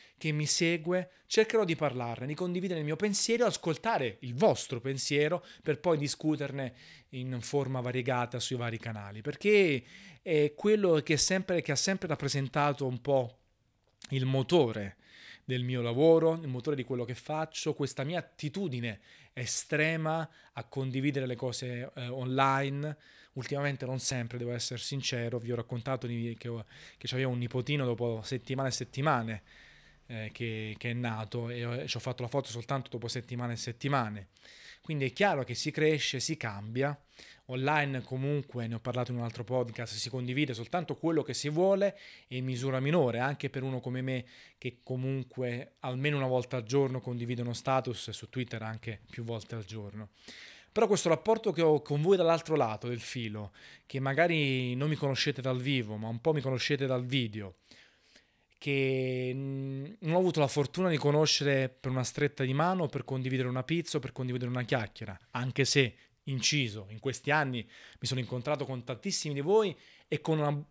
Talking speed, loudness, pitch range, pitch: 170 wpm, -32 LUFS, 120-150 Hz, 130 Hz